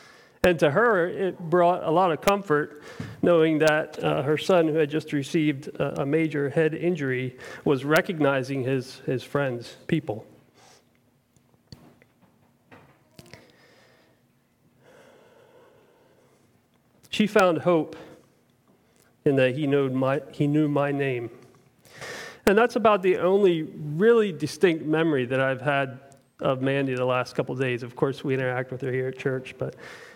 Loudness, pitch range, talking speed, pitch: -24 LUFS, 130-175 Hz, 135 wpm, 150 Hz